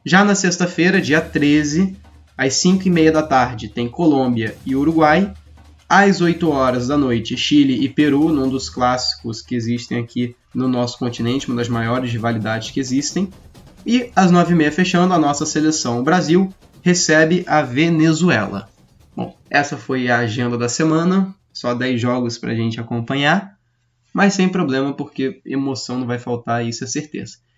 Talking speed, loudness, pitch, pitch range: 160 wpm, -17 LUFS, 135 Hz, 120-165 Hz